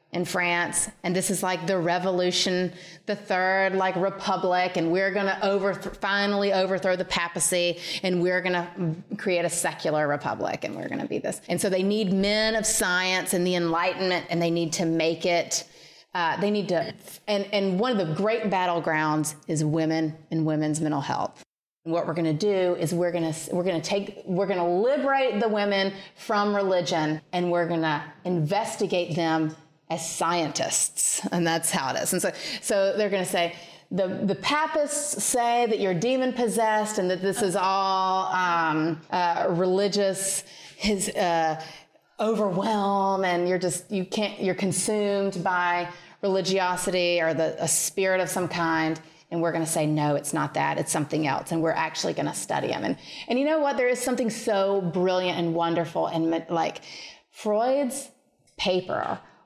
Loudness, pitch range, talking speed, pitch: -25 LUFS, 170-200 Hz, 180 wpm, 185 Hz